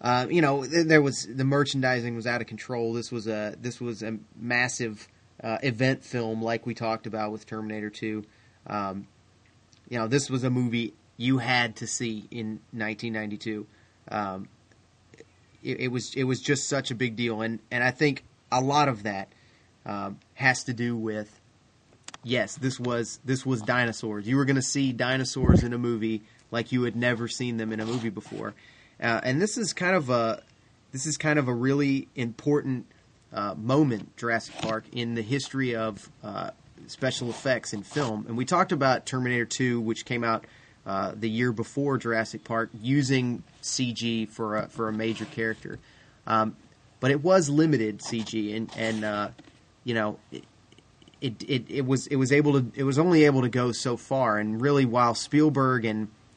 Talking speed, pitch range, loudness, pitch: 185 wpm, 110-130 Hz, -27 LUFS, 120 Hz